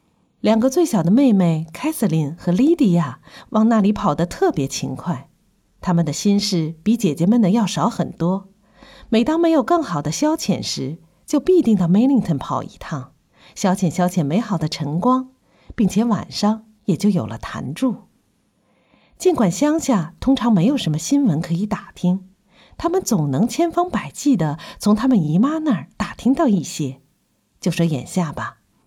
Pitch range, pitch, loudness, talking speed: 170-250 Hz, 205 Hz, -19 LUFS, 245 characters per minute